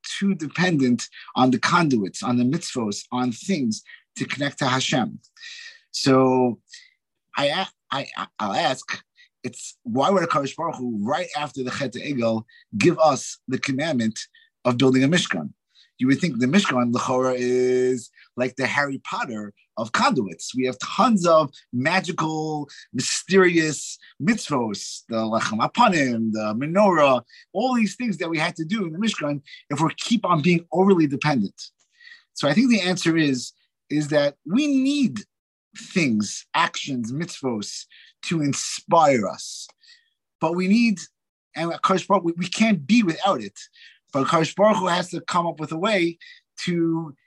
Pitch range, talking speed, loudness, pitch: 130-205 Hz, 150 wpm, -22 LUFS, 165 Hz